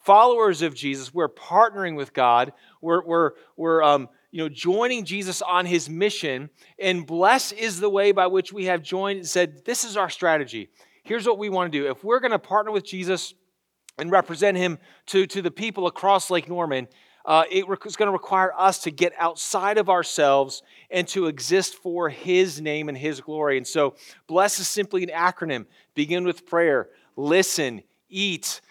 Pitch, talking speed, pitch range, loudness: 180 Hz, 185 wpm, 165-195 Hz, -23 LUFS